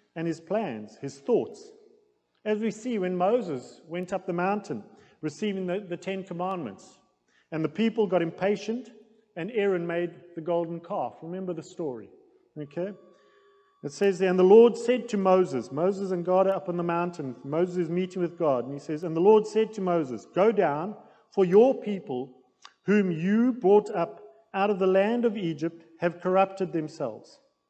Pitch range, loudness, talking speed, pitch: 170-215 Hz, -26 LUFS, 180 wpm, 185 Hz